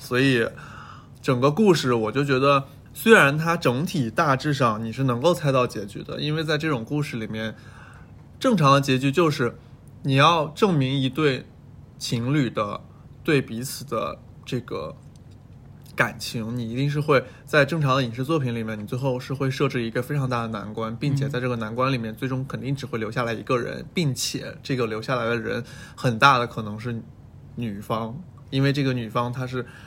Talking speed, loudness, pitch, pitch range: 275 characters per minute, -23 LUFS, 130 Hz, 120-140 Hz